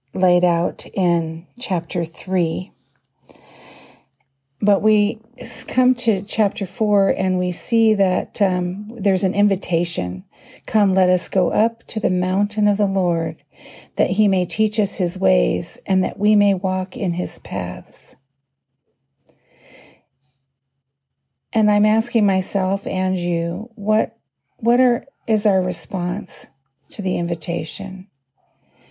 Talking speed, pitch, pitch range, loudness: 125 wpm, 190 Hz, 175-210 Hz, -20 LUFS